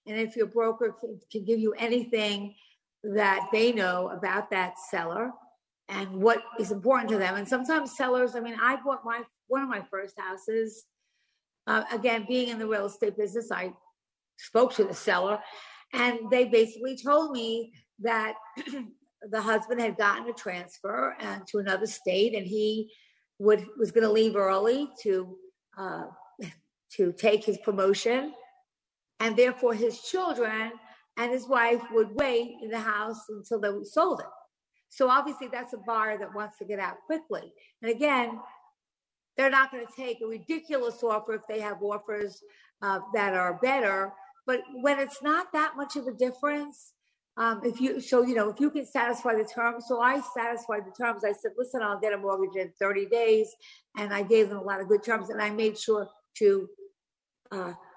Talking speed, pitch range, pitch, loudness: 175 wpm, 210-255 Hz, 225 Hz, -28 LUFS